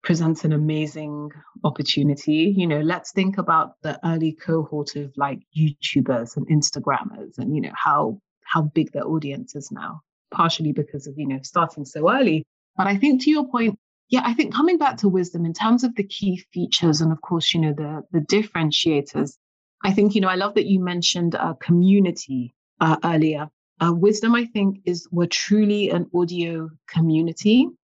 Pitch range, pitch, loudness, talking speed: 155-200 Hz, 165 Hz, -21 LUFS, 185 wpm